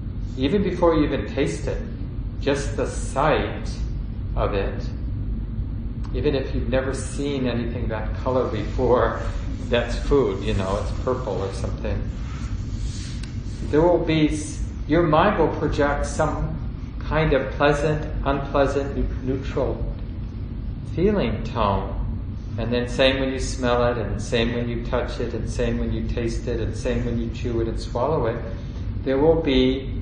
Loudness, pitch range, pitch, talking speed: -24 LUFS, 110-135 Hz, 120 Hz, 150 wpm